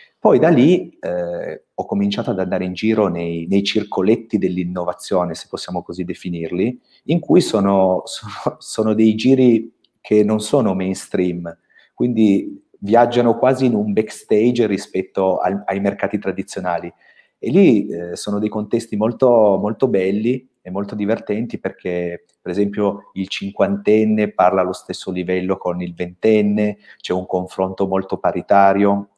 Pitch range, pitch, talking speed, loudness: 95-110 Hz, 100 Hz, 140 wpm, -18 LUFS